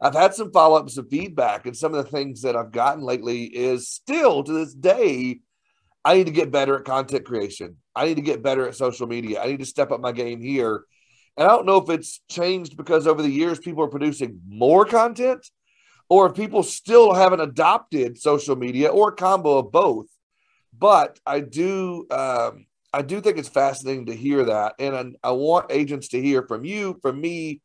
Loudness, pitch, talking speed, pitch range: -21 LUFS, 145 Hz, 210 wpm, 130-180 Hz